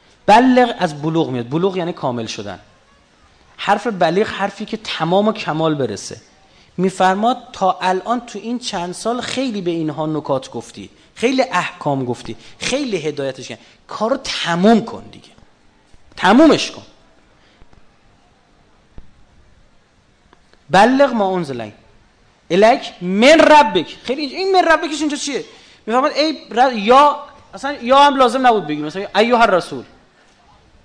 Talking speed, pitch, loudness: 130 wpm, 185 Hz, -16 LUFS